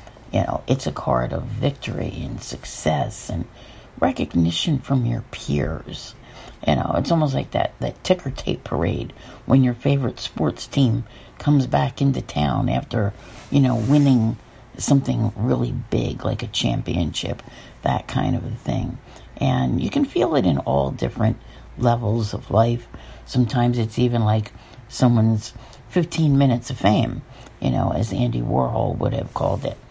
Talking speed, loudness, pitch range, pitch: 155 wpm, -22 LUFS, 110-135 Hz, 120 Hz